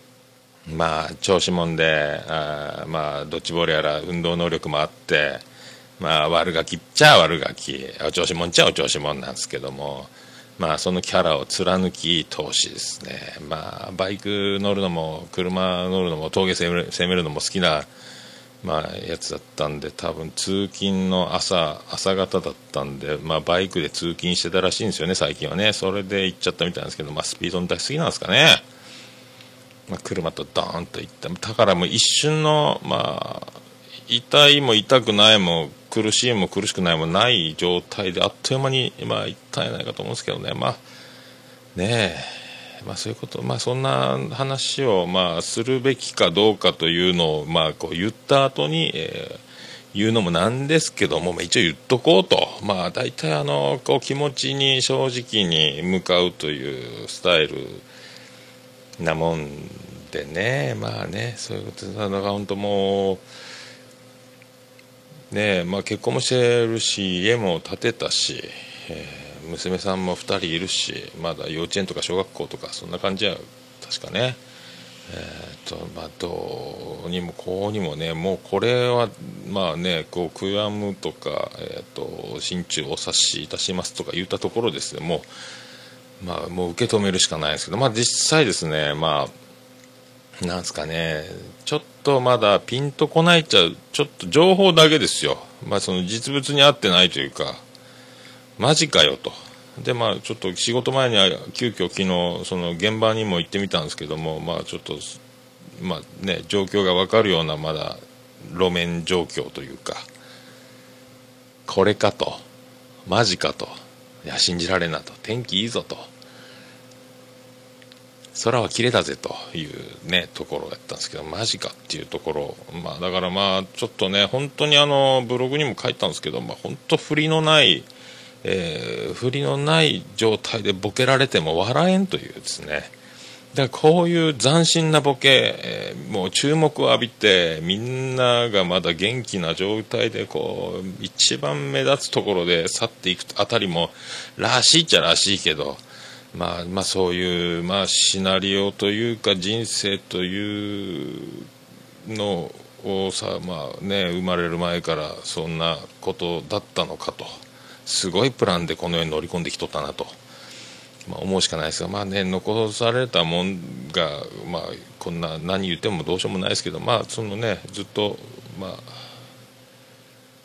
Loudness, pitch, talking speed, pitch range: -21 LUFS, 100 Hz, 305 characters per minute, 90-130 Hz